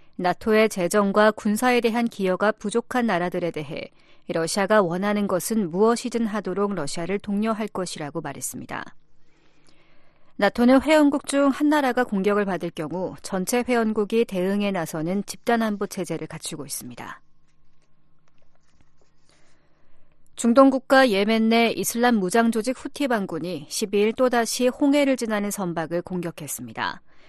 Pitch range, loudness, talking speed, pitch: 175-235 Hz, -23 LUFS, 300 characters per minute, 205 Hz